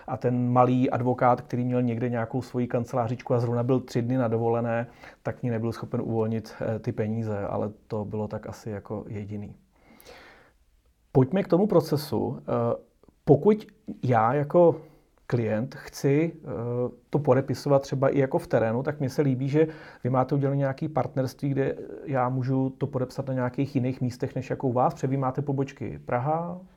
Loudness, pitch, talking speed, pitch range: -27 LUFS, 130 Hz, 165 wpm, 120-140 Hz